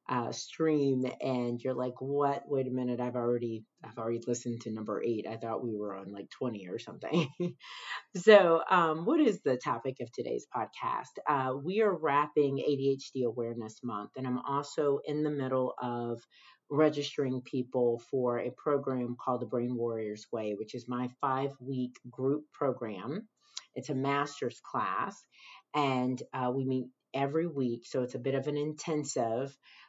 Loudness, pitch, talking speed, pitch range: -32 LUFS, 130 Hz, 165 wpm, 120-145 Hz